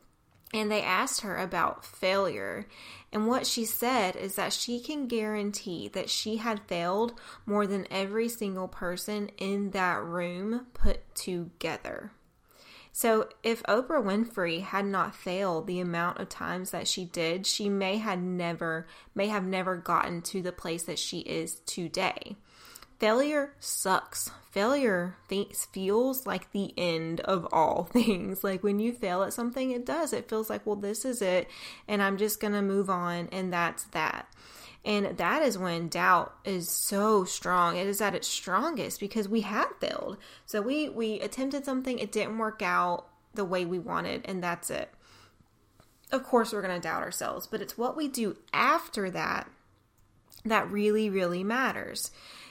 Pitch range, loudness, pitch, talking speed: 180-220 Hz, -30 LUFS, 200 Hz, 165 wpm